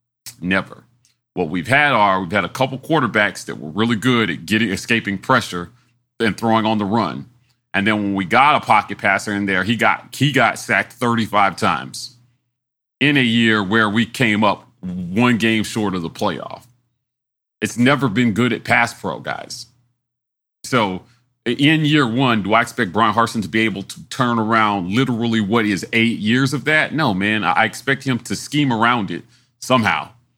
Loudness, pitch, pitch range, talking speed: -17 LUFS, 120 Hz, 110-125 Hz, 185 wpm